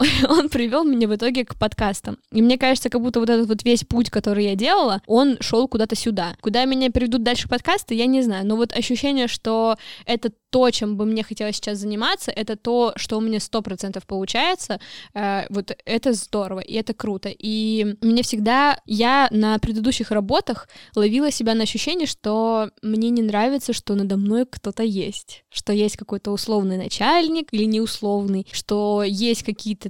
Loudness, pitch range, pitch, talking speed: -21 LUFS, 210-245 Hz, 225 Hz, 175 wpm